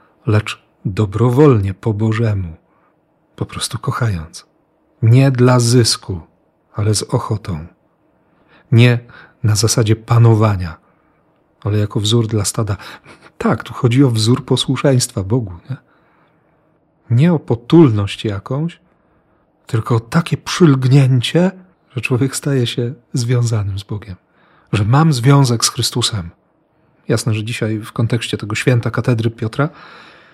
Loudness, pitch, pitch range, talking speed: -15 LUFS, 120 Hz, 110-140 Hz, 115 wpm